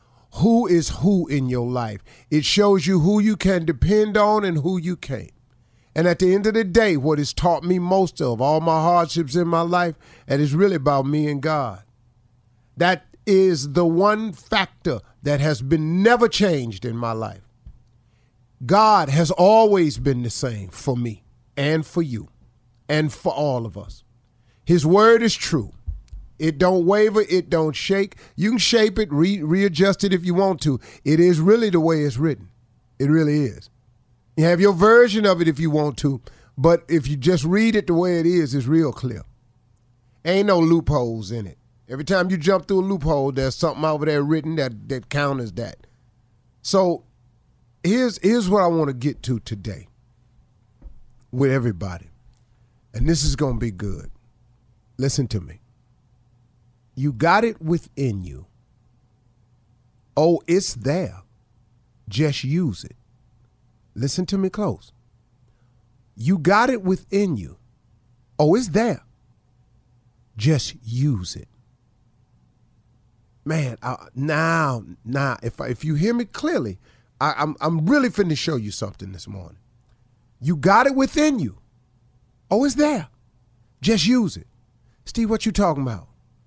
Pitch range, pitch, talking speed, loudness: 120-175 Hz, 140 Hz, 160 wpm, -20 LUFS